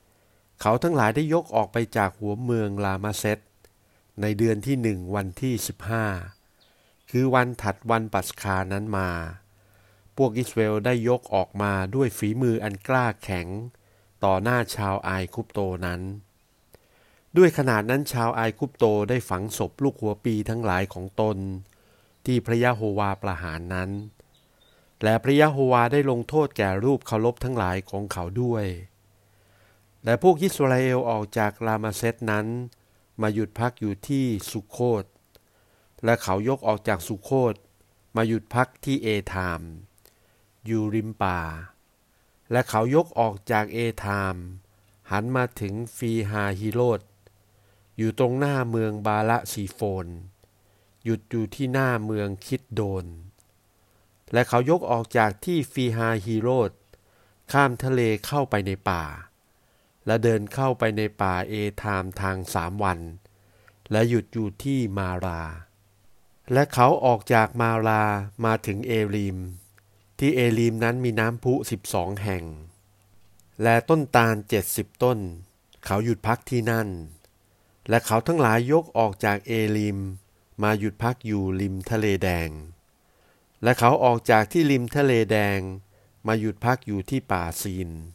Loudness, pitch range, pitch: -25 LUFS, 100-120 Hz, 105 Hz